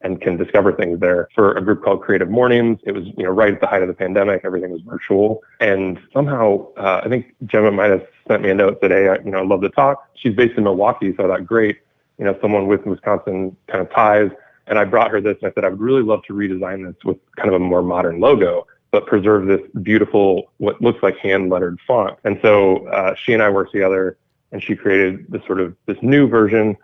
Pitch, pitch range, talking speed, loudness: 105 Hz, 95-115 Hz, 250 wpm, -17 LUFS